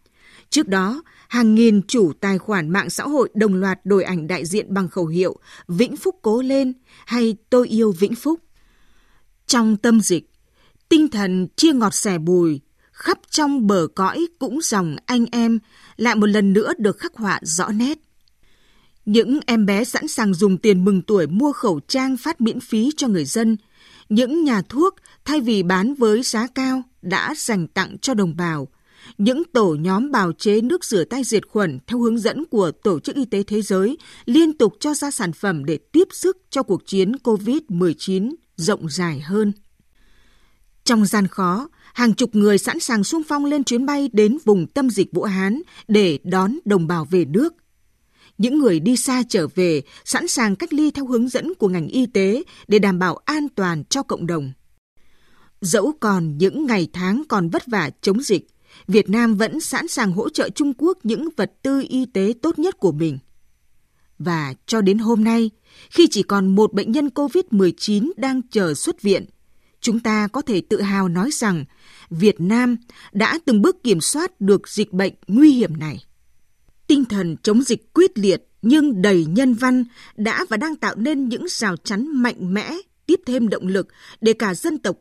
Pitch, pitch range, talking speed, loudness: 220 Hz, 190-265 Hz, 190 wpm, -19 LUFS